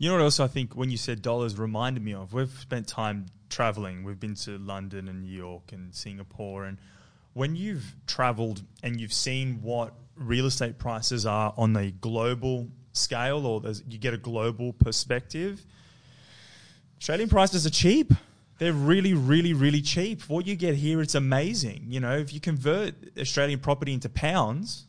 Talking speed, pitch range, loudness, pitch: 175 wpm, 110-145 Hz, -27 LUFS, 125 Hz